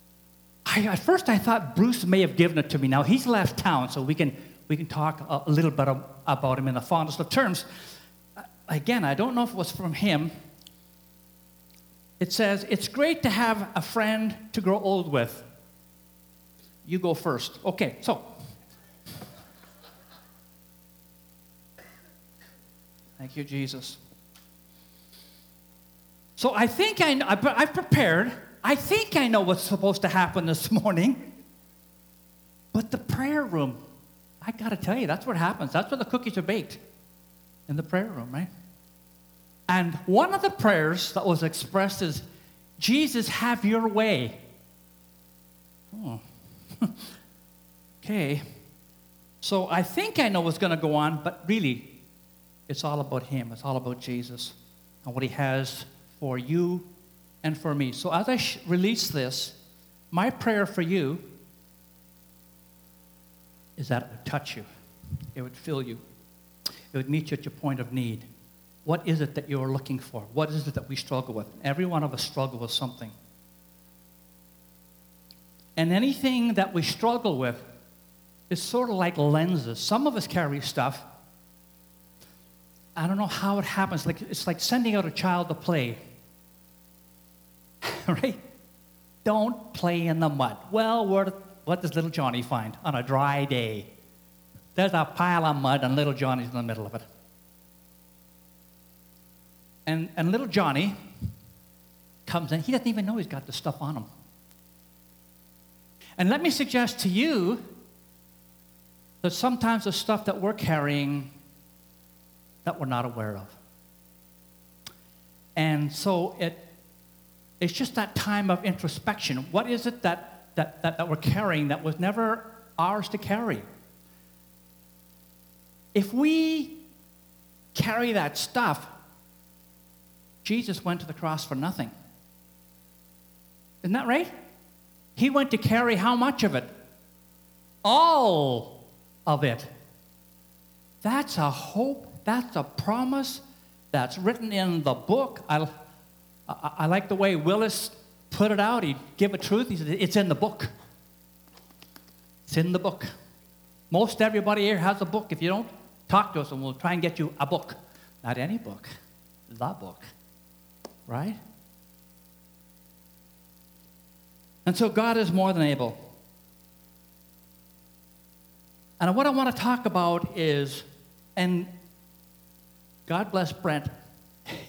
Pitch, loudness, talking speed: 135 Hz, -27 LUFS, 145 wpm